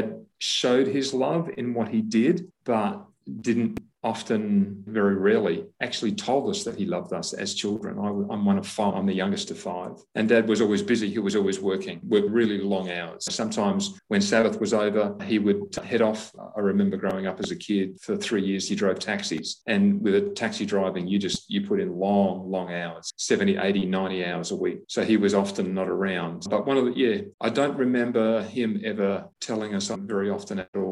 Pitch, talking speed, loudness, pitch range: 110 Hz, 210 wpm, -25 LUFS, 100-140 Hz